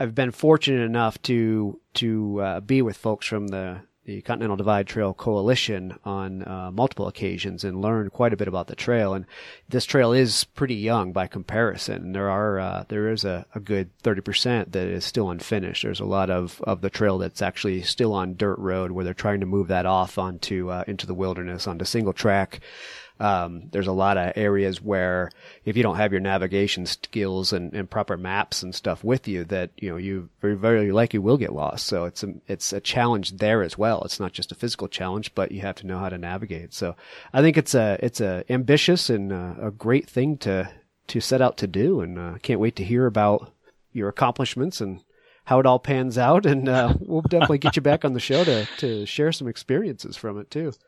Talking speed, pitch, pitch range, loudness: 220 wpm, 105 Hz, 95-120 Hz, -24 LUFS